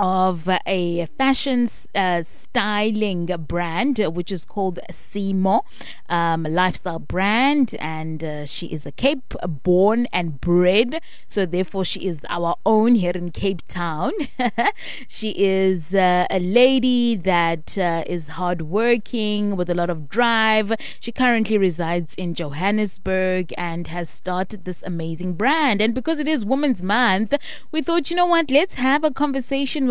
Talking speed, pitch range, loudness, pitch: 145 wpm, 175-240 Hz, -21 LUFS, 195 Hz